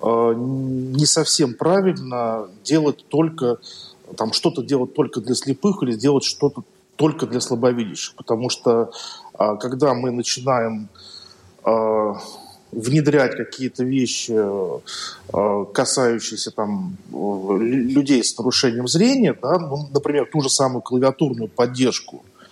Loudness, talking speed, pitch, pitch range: -20 LUFS, 105 wpm, 130 Hz, 115-150 Hz